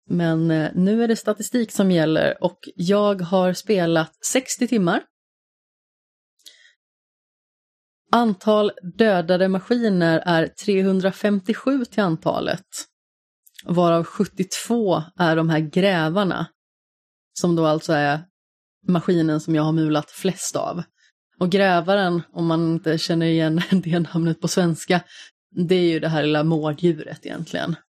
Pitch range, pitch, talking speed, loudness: 165-200 Hz, 175 Hz, 120 wpm, -21 LUFS